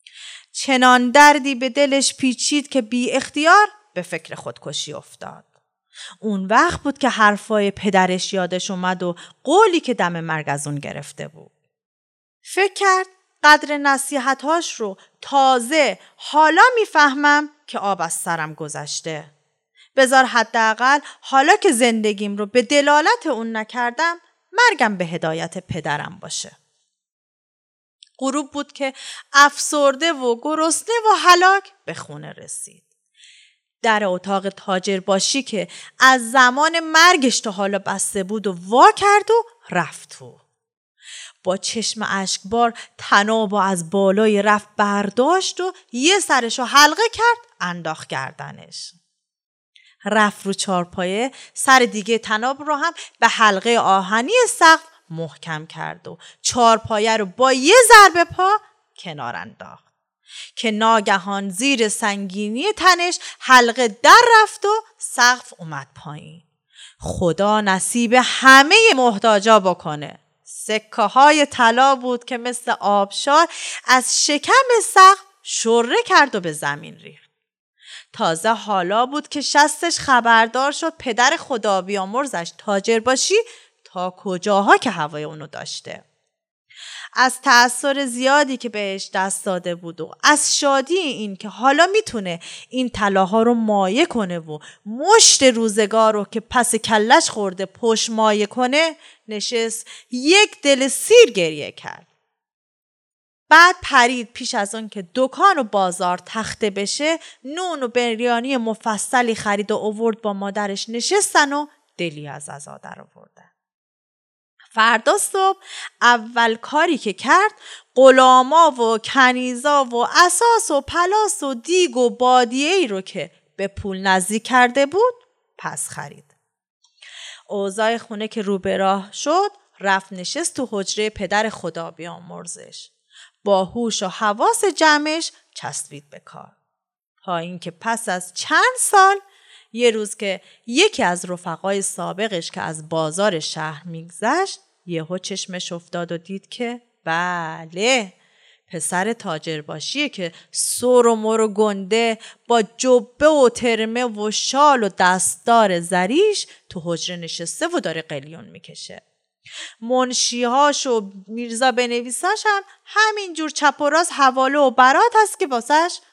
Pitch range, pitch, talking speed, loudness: 195-295 Hz, 235 Hz, 130 wpm, -17 LUFS